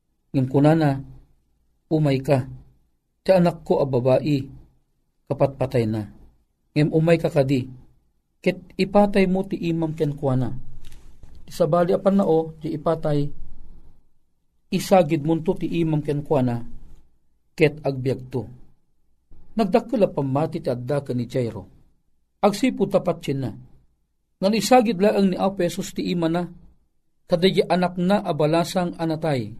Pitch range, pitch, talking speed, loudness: 125-175 Hz, 150 Hz, 130 wpm, -22 LUFS